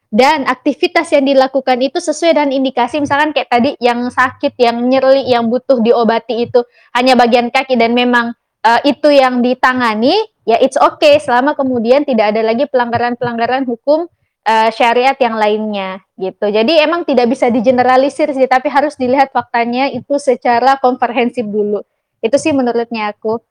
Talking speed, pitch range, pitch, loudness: 155 wpm, 235-275 Hz, 250 Hz, -12 LUFS